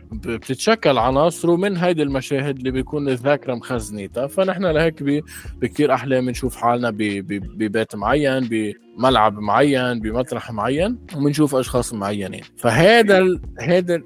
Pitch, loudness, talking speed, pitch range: 130 Hz, -19 LUFS, 110 wpm, 115-150 Hz